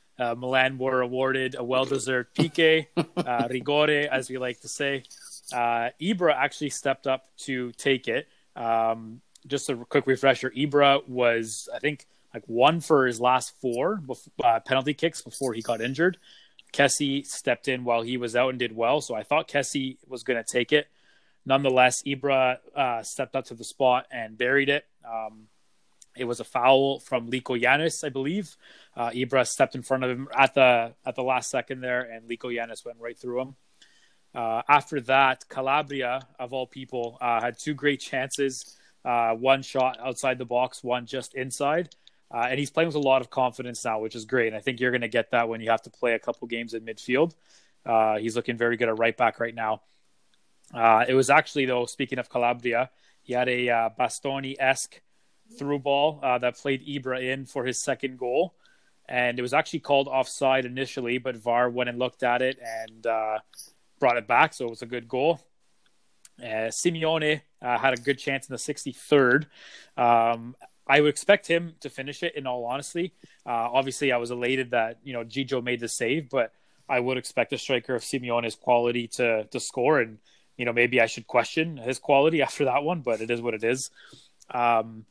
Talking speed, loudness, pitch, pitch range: 200 wpm, -26 LUFS, 130 Hz, 120-135 Hz